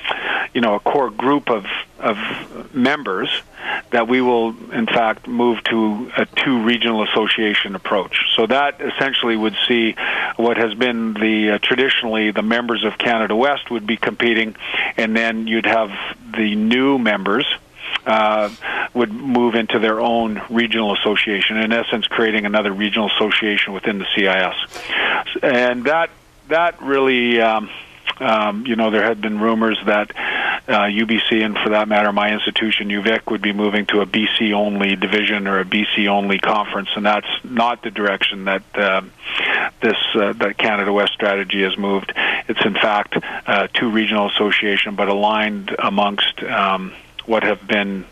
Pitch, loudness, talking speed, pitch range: 110 Hz, -17 LUFS, 160 wpm, 105-115 Hz